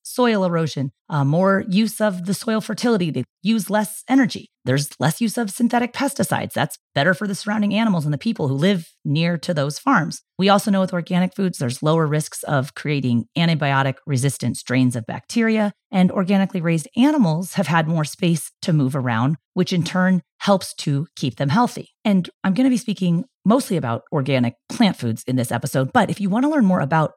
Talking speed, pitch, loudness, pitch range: 200 wpm, 180 Hz, -20 LUFS, 145-210 Hz